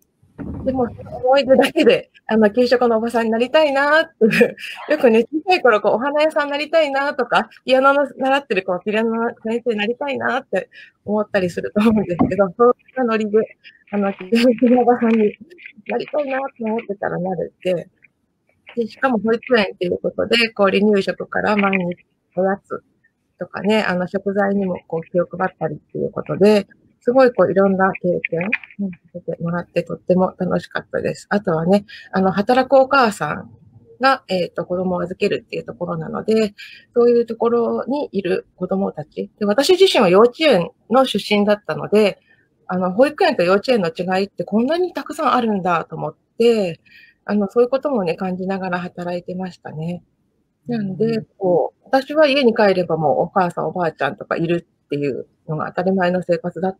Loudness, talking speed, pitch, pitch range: -18 LUFS, 380 characters per minute, 210 Hz, 180-250 Hz